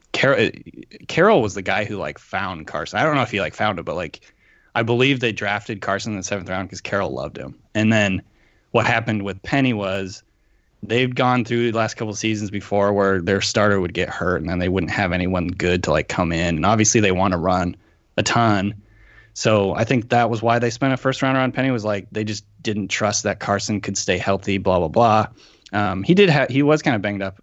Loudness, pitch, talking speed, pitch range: -20 LUFS, 105 Hz, 240 wpm, 95-115 Hz